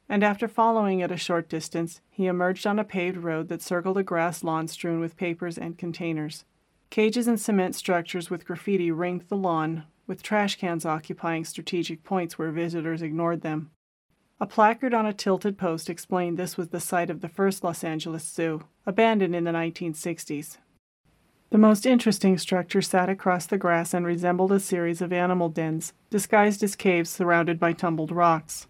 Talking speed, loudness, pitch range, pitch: 180 wpm, -26 LUFS, 165-195 Hz, 175 Hz